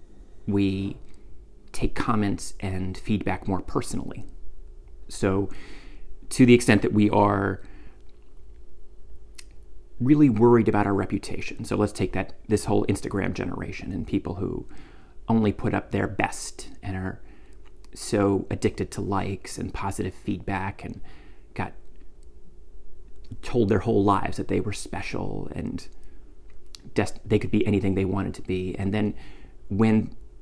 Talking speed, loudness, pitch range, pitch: 130 wpm, -25 LUFS, 70-105 Hz, 95 Hz